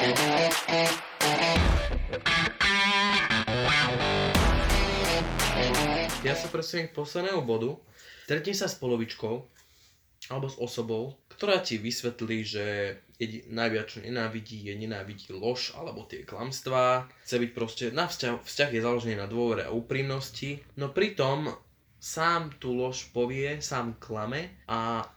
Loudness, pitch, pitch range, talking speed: -28 LUFS, 120 Hz, 110-145 Hz, 110 wpm